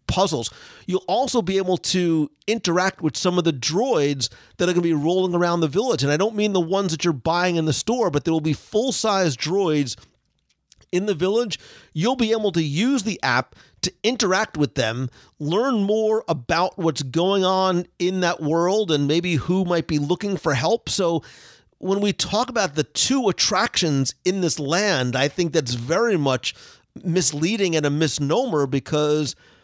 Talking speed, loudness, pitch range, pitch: 185 wpm, -21 LUFS, 150-195 Hz, 175 Hz